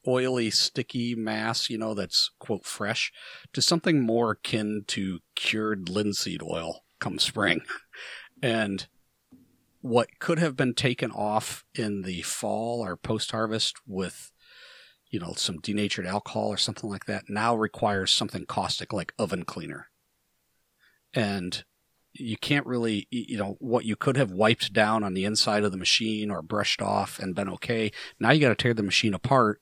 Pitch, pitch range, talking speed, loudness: 110 Hz, 105-120 Hz, 160 wpm, -27 LUFS